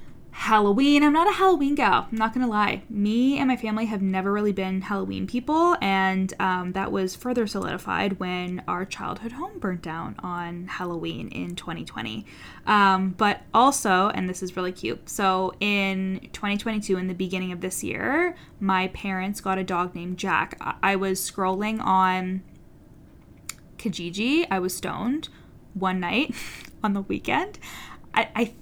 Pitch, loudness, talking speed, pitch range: 195 Hz, -25 LUFS, 160 wpm, 185-220 Hz